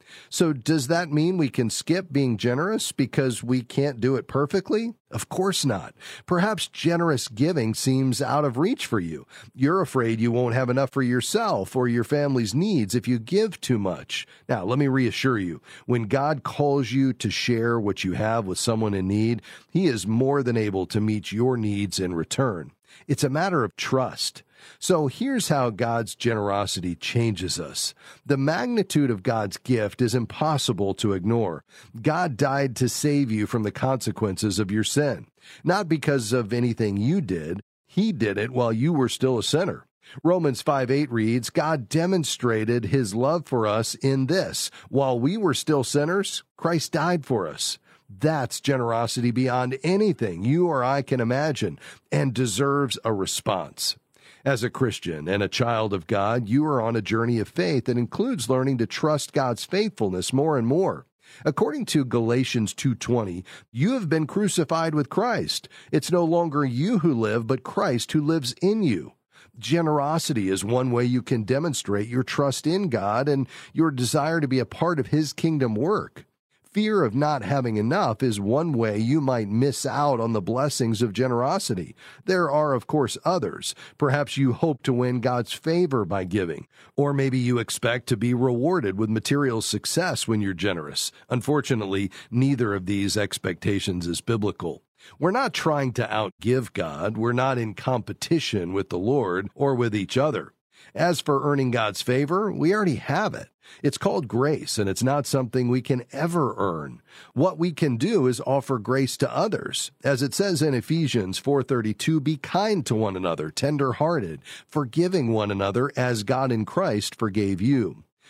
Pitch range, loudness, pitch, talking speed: 115-150 Hz, -24 LUFS, 130 Hz, 175 wpm